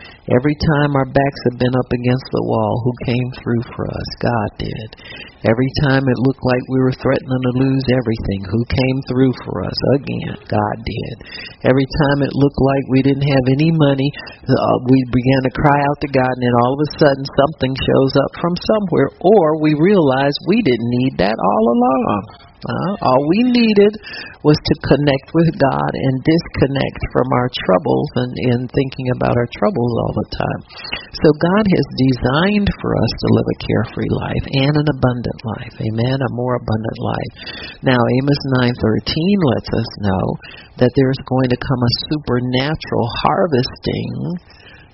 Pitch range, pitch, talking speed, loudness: 120-140 Hz, 130 Hz, 175 wpm, -16 LUFS